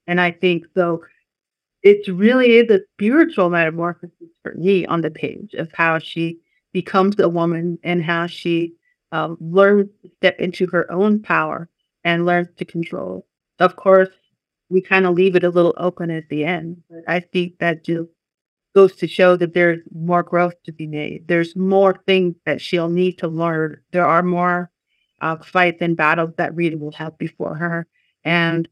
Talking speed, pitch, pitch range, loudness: 180 wpm, 175 Hz, 165-185 Hz, -18 LUFS